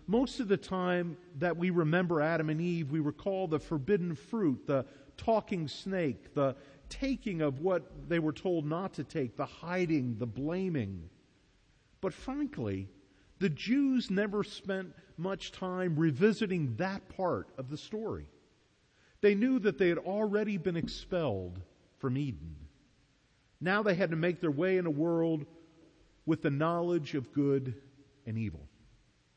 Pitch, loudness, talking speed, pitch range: 165 Hz, -33 LUFS, 150 wpm, 140-190 Hz